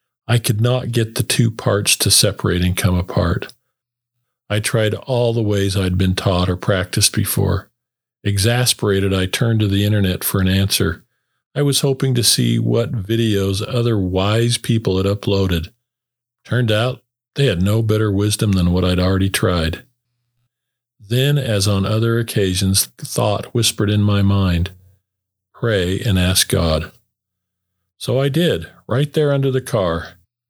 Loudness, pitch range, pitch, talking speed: -17 LUFS, 95-120 Hz, 105 Hz, 155 wpm